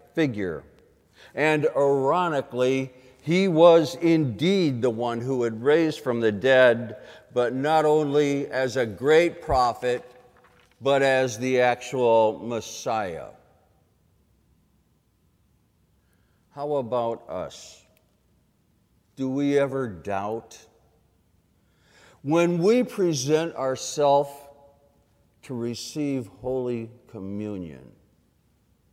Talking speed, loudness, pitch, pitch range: 85 wpm, -23 LUFS, 130 Hz, 115-145 Hz